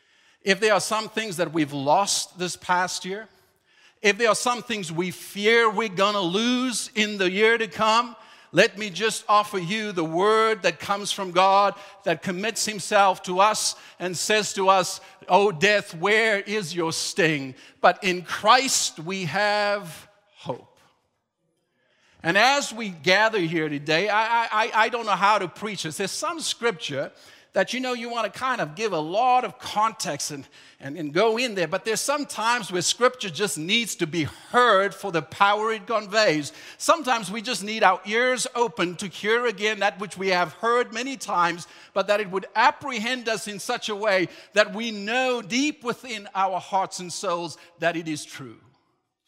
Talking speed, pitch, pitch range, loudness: 185 wpm, 205 Hz, 180-225 Hz, -23 LUFS